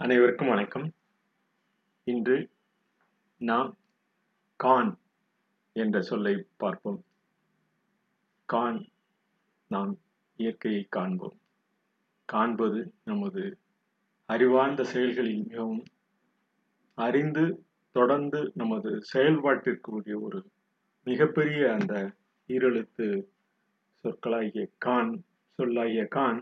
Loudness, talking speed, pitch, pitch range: -29 LUFS, 65 wpm, 190 Hz, 125-205 Hz